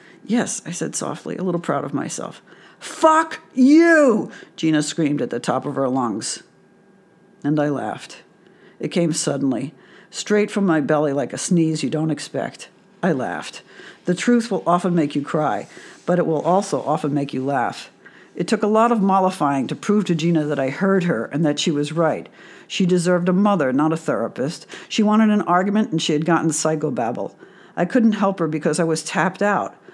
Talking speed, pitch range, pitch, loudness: 190 wpm, 155-200 Hz, 170 Hz, -20 LUFS